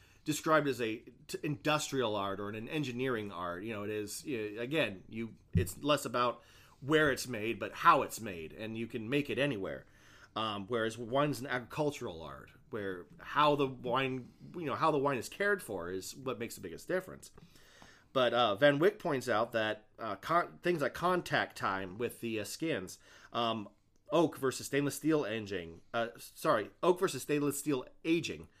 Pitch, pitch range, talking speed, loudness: 125 Hz, 110-145 Hz, 180 wpm, -34 LUFS